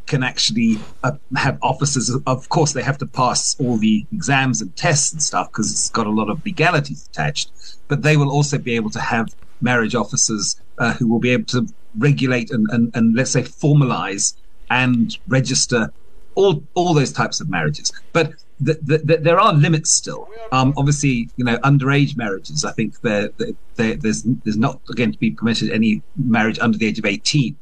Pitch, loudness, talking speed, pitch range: 130 Hz, -18 LUFS, 190 wpm, 115-145 Hz